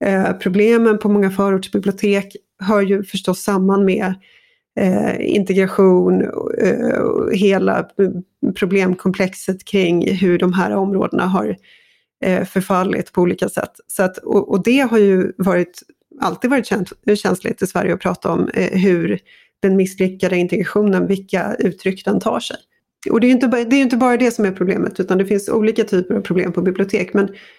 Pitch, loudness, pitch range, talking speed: 195 Hz, -17 LUFS, 185-210 Hz, 145 wpm